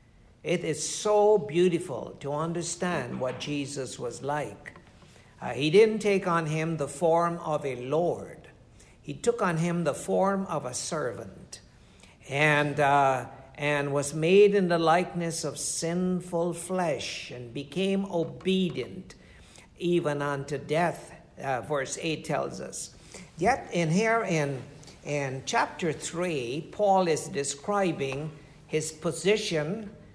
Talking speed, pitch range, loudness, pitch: 125 wpm, 145-180 Hz, -28 LUFS, 160 Hz